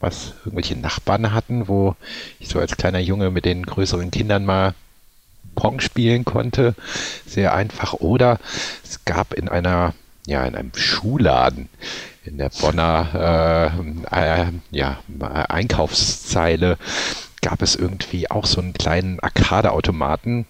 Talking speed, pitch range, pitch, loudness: 130 wpm, 80-105 Hz, 90 Hz, -20 LUFS